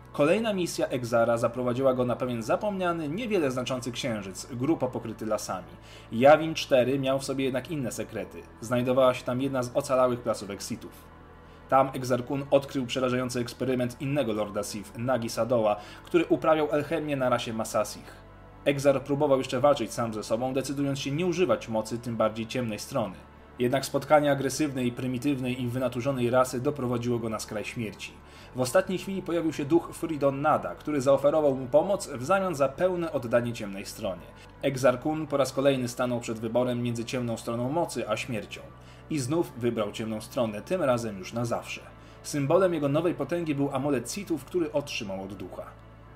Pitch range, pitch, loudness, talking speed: 115-145 Hz, 125 Hz, -28 LUFS, 165 wpm